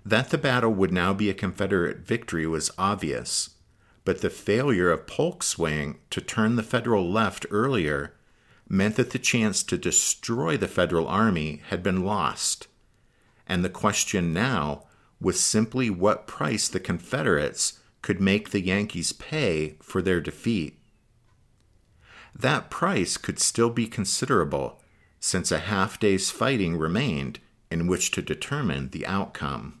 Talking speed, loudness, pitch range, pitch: 140 wpm, -25 LUFS, 90-115 Hz, 100 Hz